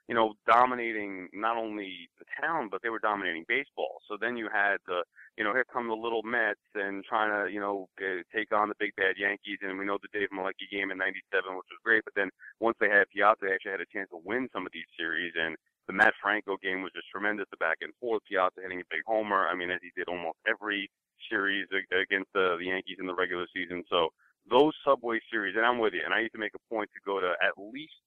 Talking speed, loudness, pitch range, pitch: 250 wpm, -30 LUFS, 95-115 Hz, 100 Hz